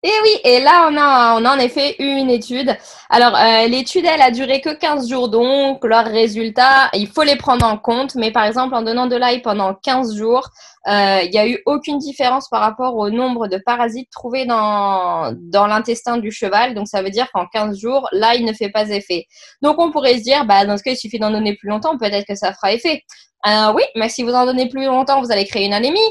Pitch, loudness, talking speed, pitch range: 240 Hz, -15 LUFS, 245 wpm, 215-270 Hz